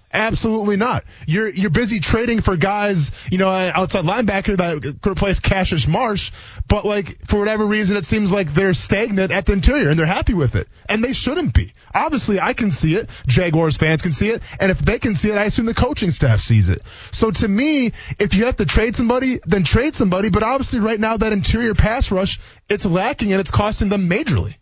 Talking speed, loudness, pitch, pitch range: 215 wpm, -18 LUFS, 200 Hz, 165-220 Hz